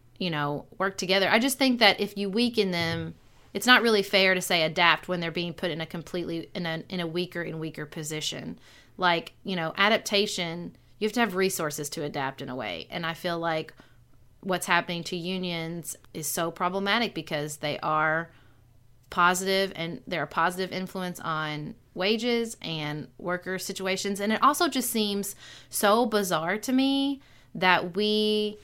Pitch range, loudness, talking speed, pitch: 160-200 Hz, -26 LUFS, 175 wpm, 180 Hz